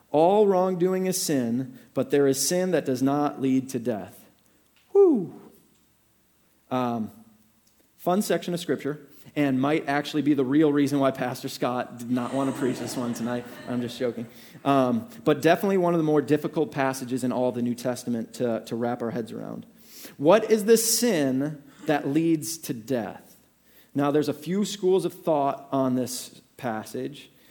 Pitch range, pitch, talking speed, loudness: 125-165 Hz, 140 Hz, 170 wpm, -25 LUFS